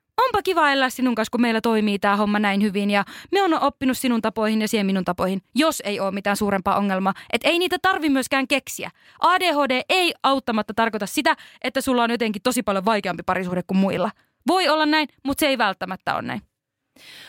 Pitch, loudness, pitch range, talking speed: 235 Hz, -21 LUFS, 200-285 Hz, 200 wpm